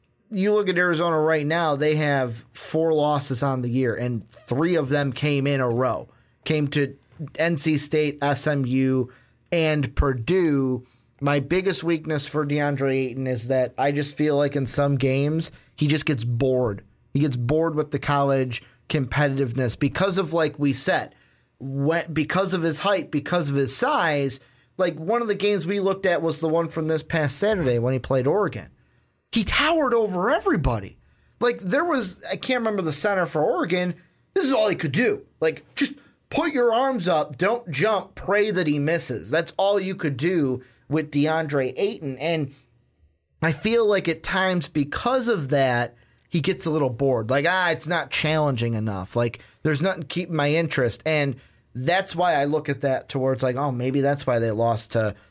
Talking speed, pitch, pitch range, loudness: 180 wpm, 150 Hz, 135-175 Hz, -23 LUFS